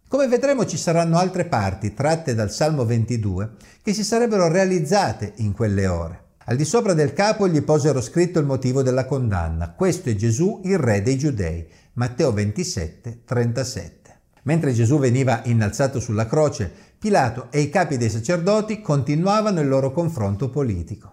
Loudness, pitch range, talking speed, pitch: -21 LUFS, 110-170 Hz, 160 wpm, 135 Hz